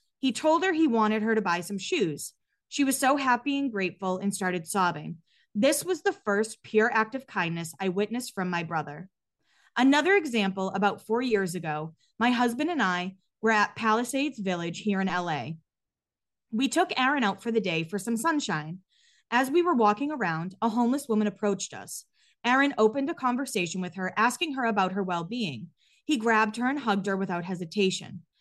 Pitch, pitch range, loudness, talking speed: 215 Hz, 185-260 Hz, -27 LUFS, 190 wpm